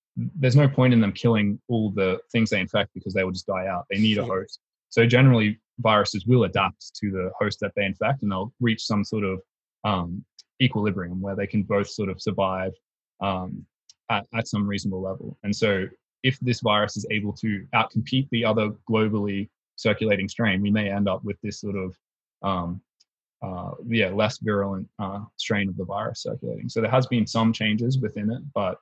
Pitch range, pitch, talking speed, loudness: 100-115 Hz, 105 Hz, 200 wpm, -24 LUFS